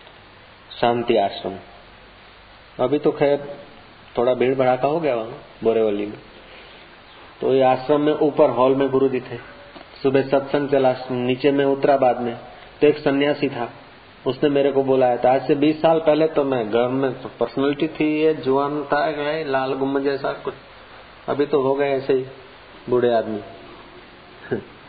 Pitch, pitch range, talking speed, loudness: 135 Hz, 120-145 Hz, 160 wpm, -20 LUFS